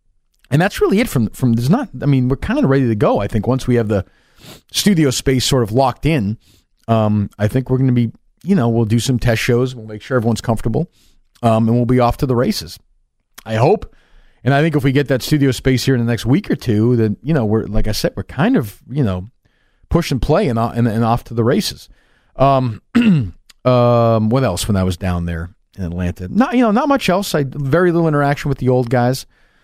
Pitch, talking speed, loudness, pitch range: 125 Hz, 245 wpm, -16 LUFS, 110-140 Hz